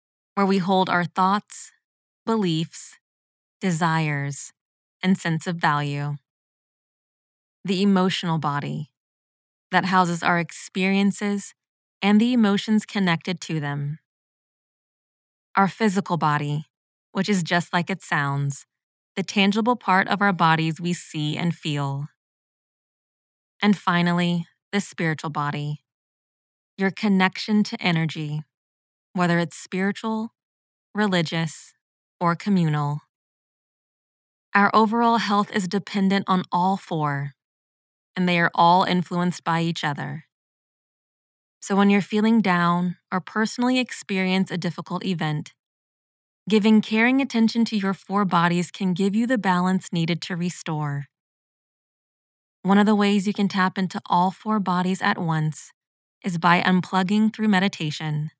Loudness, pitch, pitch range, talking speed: -22 LUFS, 185 Hz, 160-200 Hz, 120 wpm